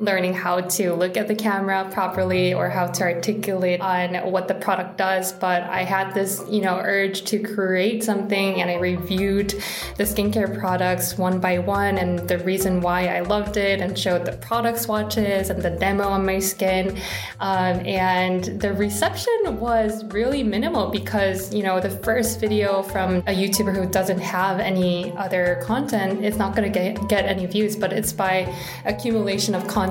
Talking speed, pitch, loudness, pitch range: 180 wpm, 195 Hz, -22 LUFS, 185-205 Hz